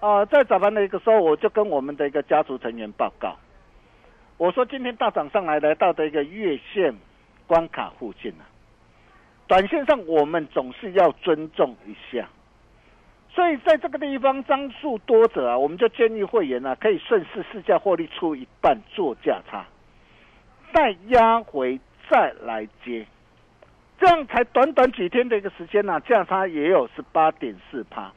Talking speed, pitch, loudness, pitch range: 255 characters per minute, 205 Hz, -22 LUFS, 155-250 Hz